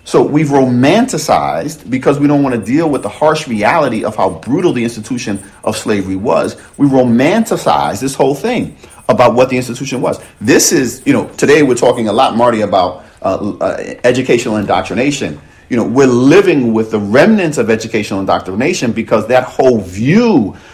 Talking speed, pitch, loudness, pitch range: 175 wpm, 125 Hz, -12 LUFS, 110-140 Hz